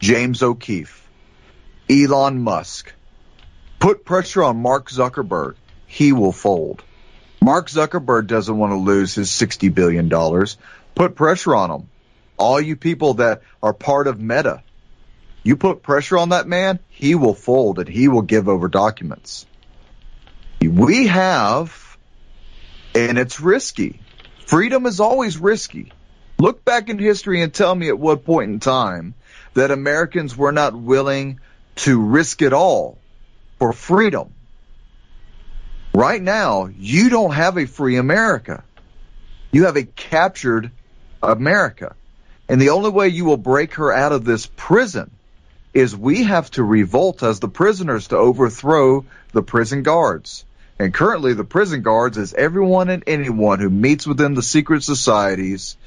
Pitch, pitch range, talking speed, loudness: 135 Hz, 115-170 Hz, 145 wpm, -17 LUFS